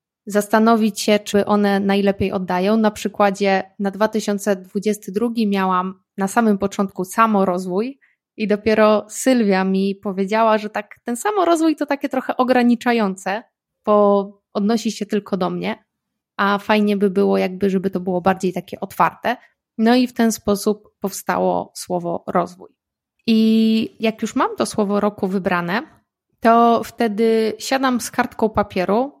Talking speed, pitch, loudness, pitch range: 140 wpm, 210 Hz, -19 LUFS, 195-225 Hz